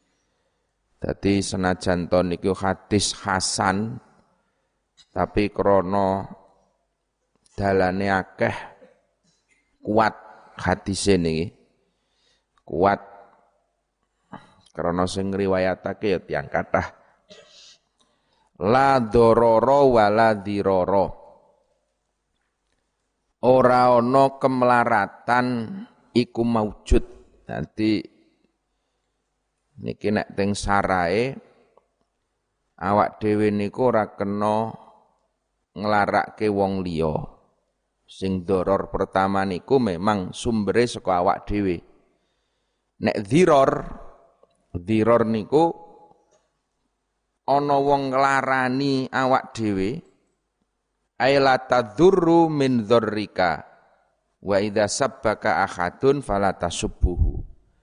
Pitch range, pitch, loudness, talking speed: 95-125 Hz, 105 Hz, -22 LUFS, 70 wpm